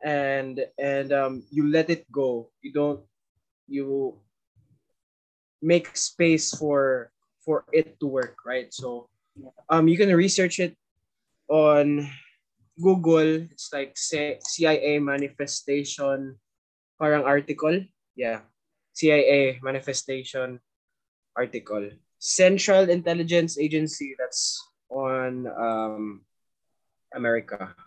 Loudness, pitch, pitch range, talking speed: -24 LUFS, 140 Hz, 130-160 Hz, 95 wpm